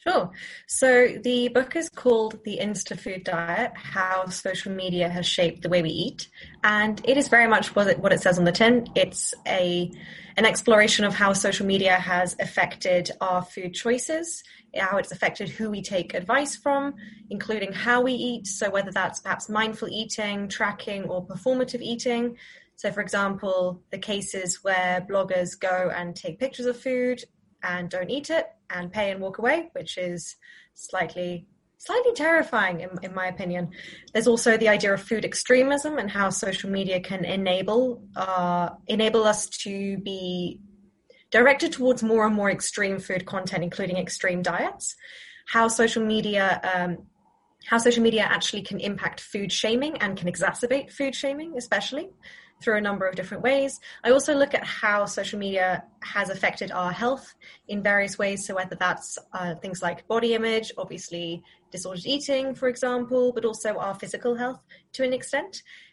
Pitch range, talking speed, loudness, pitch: 185-240 Hz, 170 wpm, -25 LUFS, 205 Hz